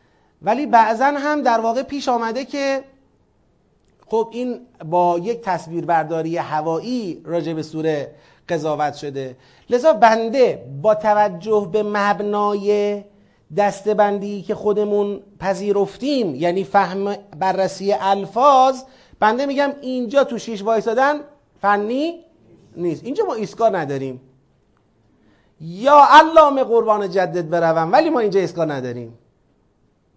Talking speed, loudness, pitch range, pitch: 110 wpm, -18 LUFS, 170-245 Hz, 205 Hz